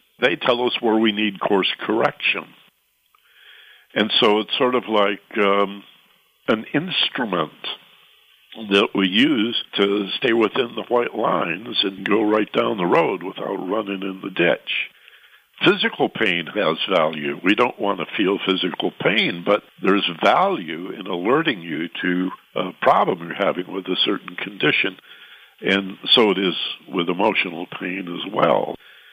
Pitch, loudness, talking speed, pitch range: 100 Hz, -20 LUFS, 150 wpm, 95-110 Hz